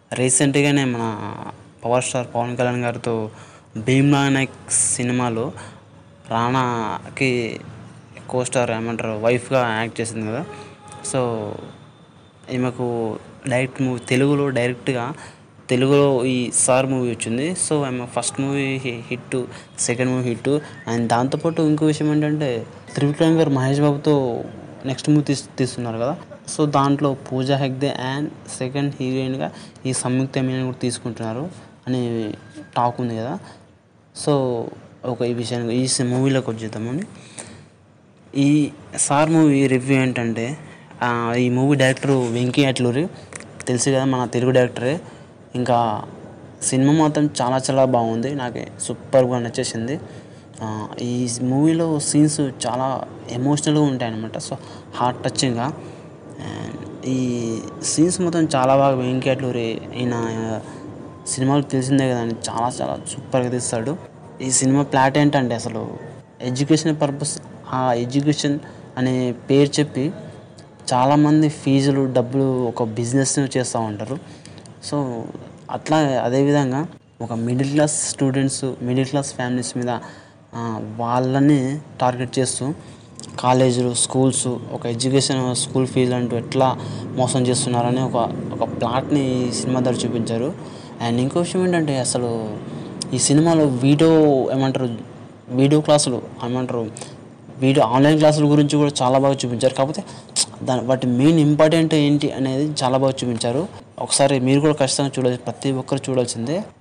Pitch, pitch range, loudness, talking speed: 130 Hz, 120-140 Hz, -20 LUFS, 120 wpm